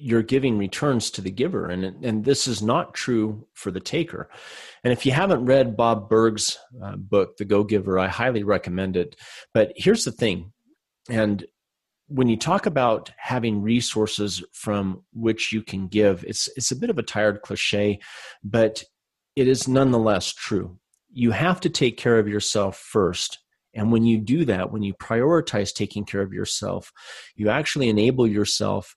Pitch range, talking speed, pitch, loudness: 105-125 Hz, 170 wpm, 110 Hz, -23 LUFS